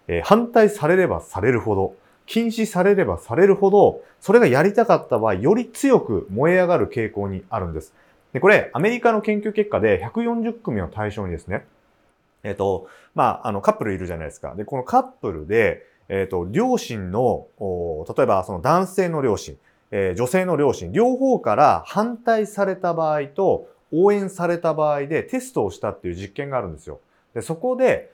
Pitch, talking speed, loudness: 190 Hz, 350 characters per minute, -20 LUFS